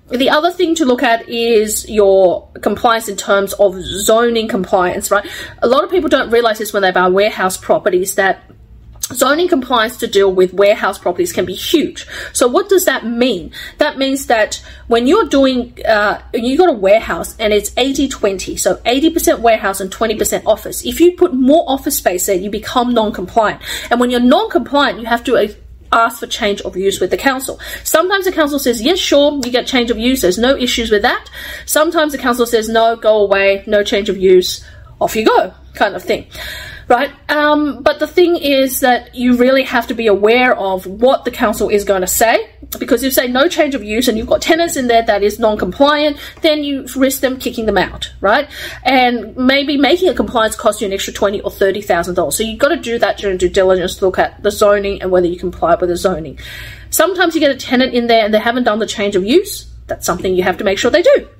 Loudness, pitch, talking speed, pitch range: -13 LUFS, 235 Hz, 220 wpm, 205-285 Hz